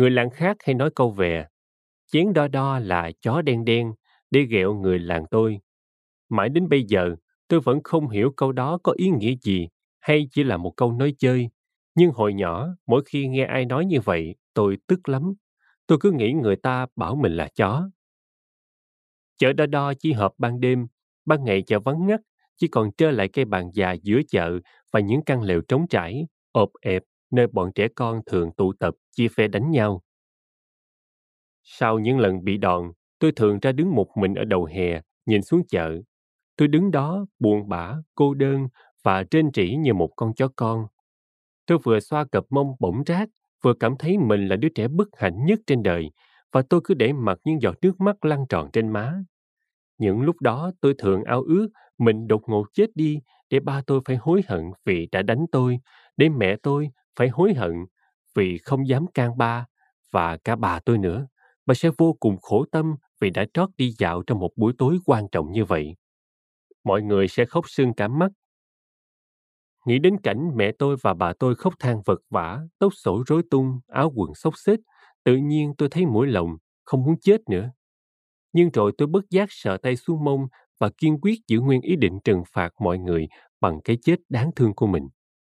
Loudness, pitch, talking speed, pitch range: -22 LUFS, 125 Hz, 200 wpm, 100-155 Hz